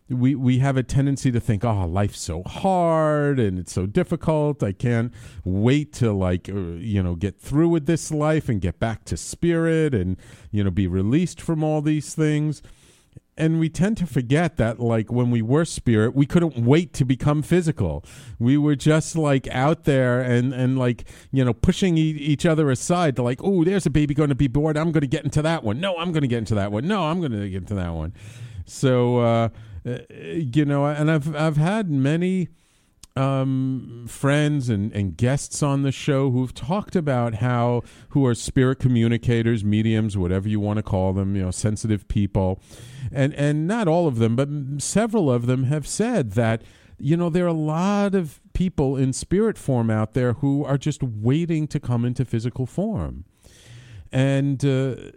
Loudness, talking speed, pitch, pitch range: -22 LUFS, 200 wpm, 135 Hz, 115-155 Hz